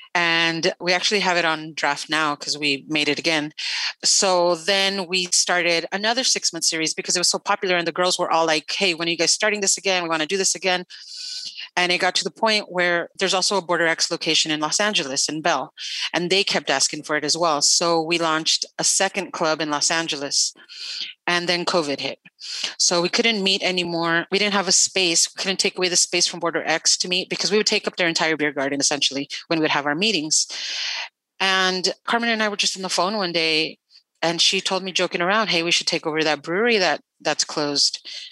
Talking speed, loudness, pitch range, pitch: 235 wpm, -20 LUFS, 160-195 Hz, 175 Hz